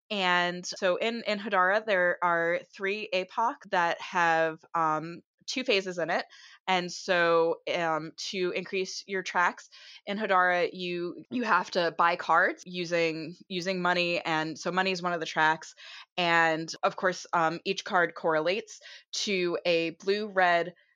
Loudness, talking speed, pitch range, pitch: -28 LUFS, 150 wpm, 170-190 Hz, 180 Hz